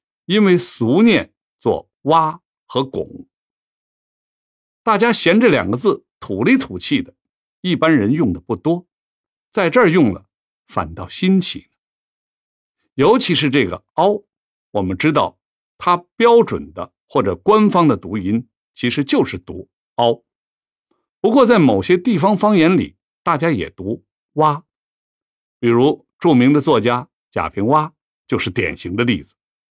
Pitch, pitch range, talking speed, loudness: 170 Hz, 145-210 Hz, 190 characters per minute, -16 LUFS